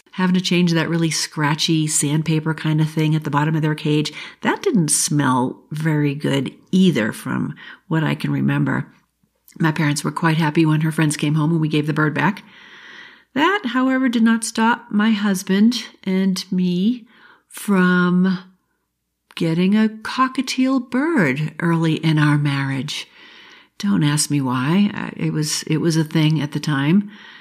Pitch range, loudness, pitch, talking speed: 150-210 Hz, -19 LUFS, 165 Hz, 160 wpm